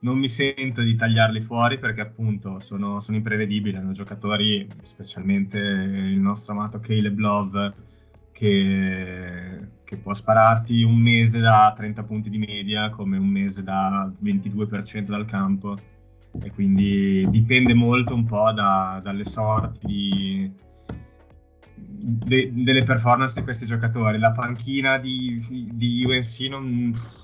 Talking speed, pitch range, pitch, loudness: 130 wpm, 100-115 Hz, 105 Hz, -22 LUFS